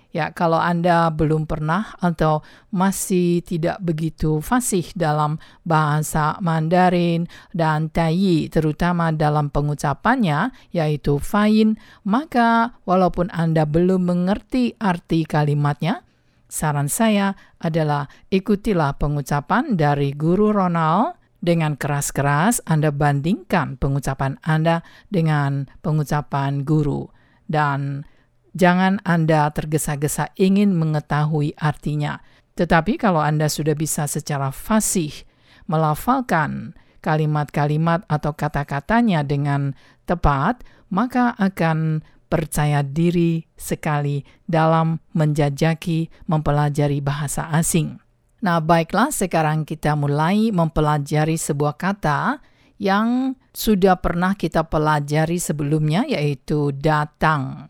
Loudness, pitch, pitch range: -20 LUFS, 160 Hz, 150-180 Hz